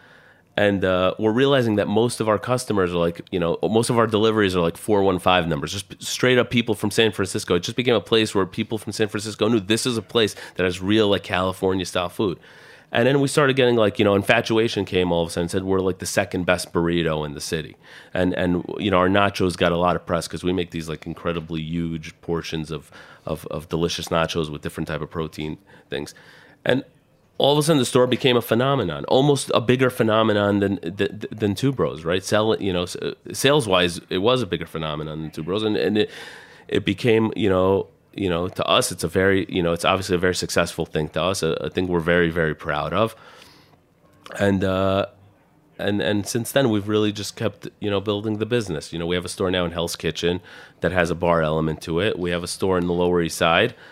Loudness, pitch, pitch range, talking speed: -22 LUFS, 95 Hz, 85-110 Hz, 235 wpm